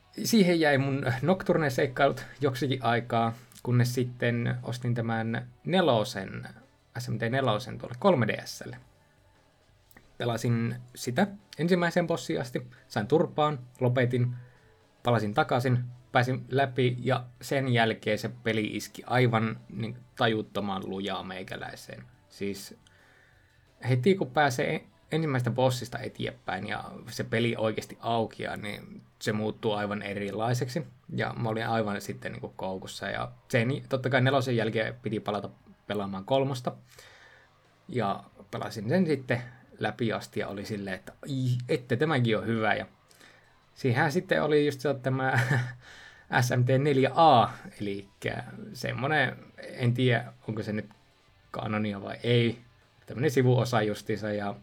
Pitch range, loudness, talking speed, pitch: 110-130 Hz, -29 LUFS, 120 wpm, 120 Hz